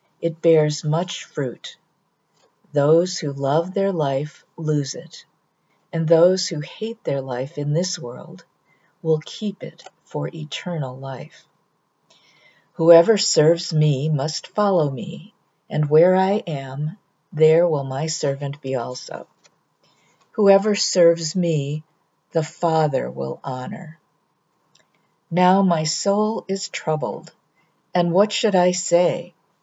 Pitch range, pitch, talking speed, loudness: 150-180 Hz, 165 Hz, 120 wpm, -20 LUFS